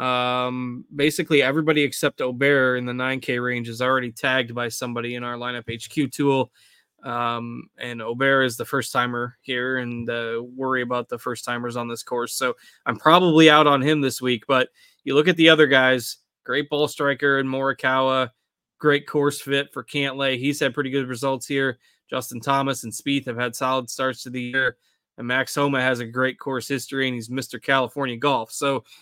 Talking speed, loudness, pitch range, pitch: 190 wpm, -22 LUFS, 125-140 Hz, 130 Hz